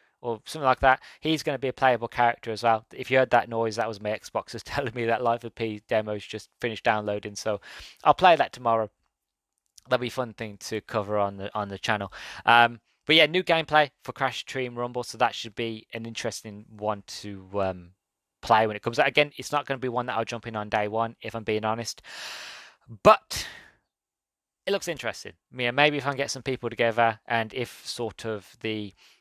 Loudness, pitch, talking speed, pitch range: -26 LUFS, 115 Hz, 225 wpm, 105-125 Hz